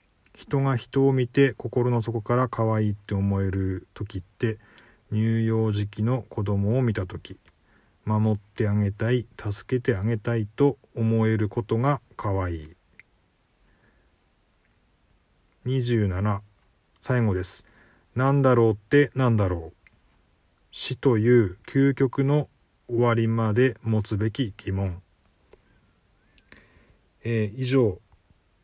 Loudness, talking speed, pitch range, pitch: -25 LUFS, 200 characters per minute, 95-120 Hz, 110 Hz